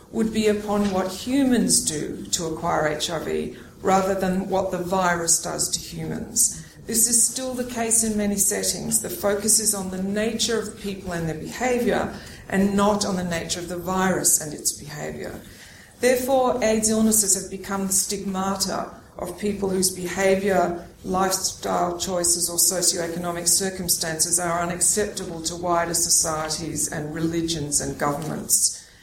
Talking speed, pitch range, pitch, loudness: 150 wpm, 175-205 Hz, 190 Hz, -22 LUFS